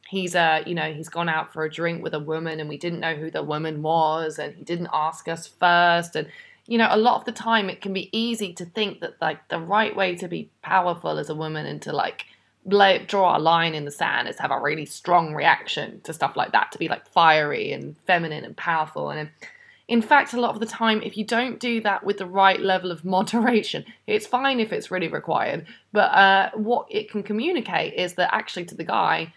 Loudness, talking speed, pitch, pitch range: -23 LUFS, 240 wpm, 185 Hz, 165-225 Hz